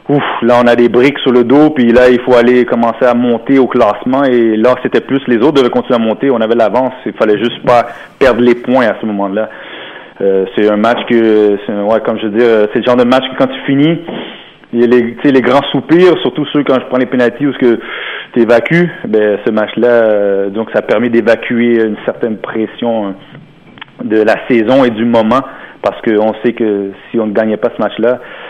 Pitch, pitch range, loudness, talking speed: 120 Hz, 110-125 Hz, -10 LUFS, 225 wpm